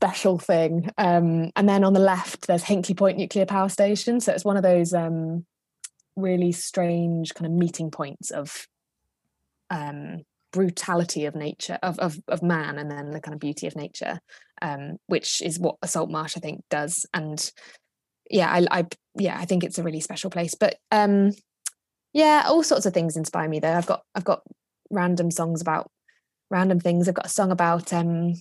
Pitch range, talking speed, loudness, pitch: 160-190 Hz, 190 wpm, -24 LUFS, 175 Hz